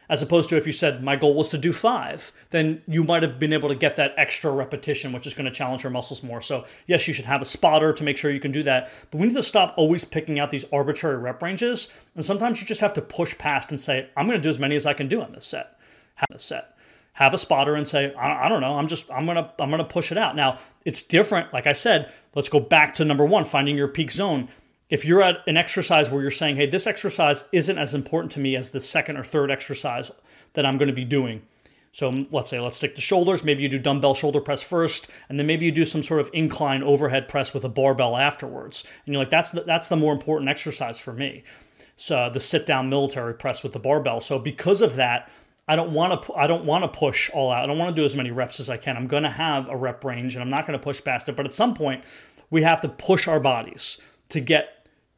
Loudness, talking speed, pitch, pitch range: -23 LUFS, 270 wpm, 145 Hz, 135-160 Hz